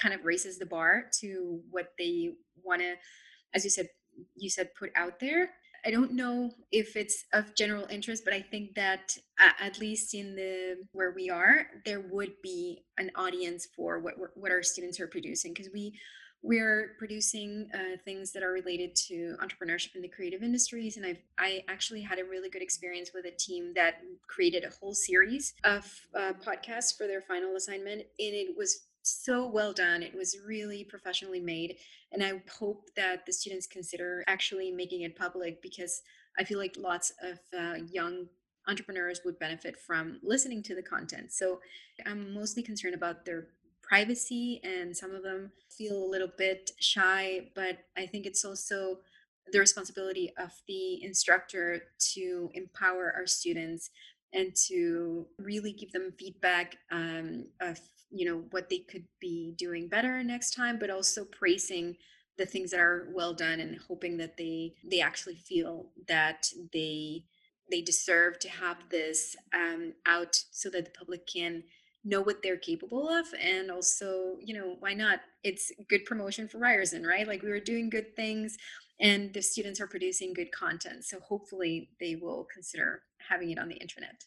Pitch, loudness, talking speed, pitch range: 190 Hz, -32 LUFS, 175 wpm, 180-210 Hz